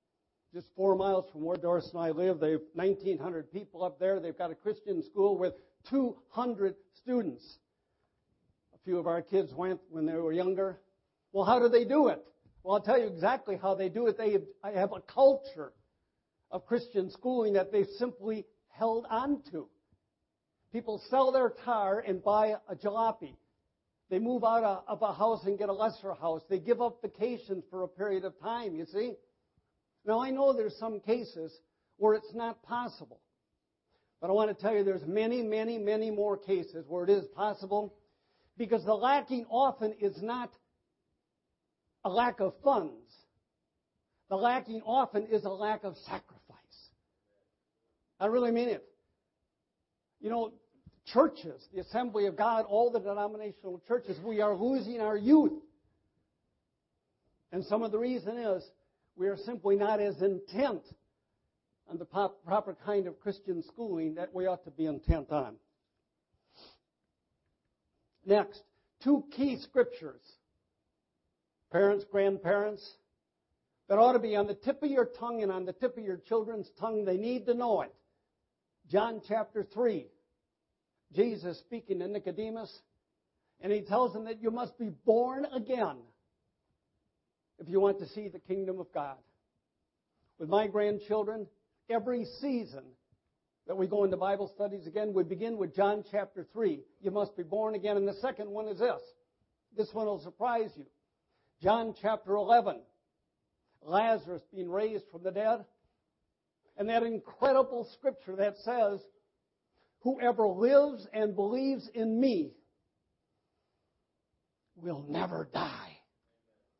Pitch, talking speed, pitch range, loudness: 210 Hz, 155 wpm, 190-235 Hz, -32 LUFS